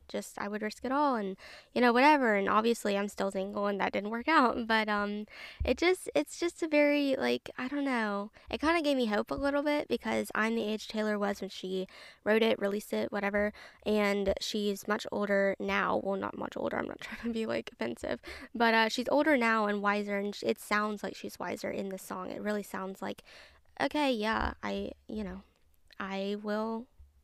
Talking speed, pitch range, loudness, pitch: 215 wpm, 200-245 Hz, -31 LUFS, 210 Hz